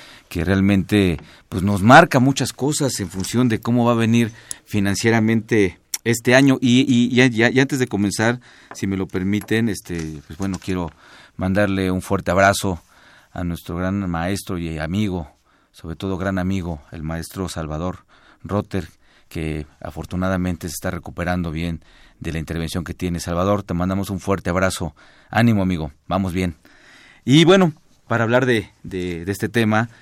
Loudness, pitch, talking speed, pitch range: -20 LUFS, 95 Hz, 160 wpm, 85-115 Hz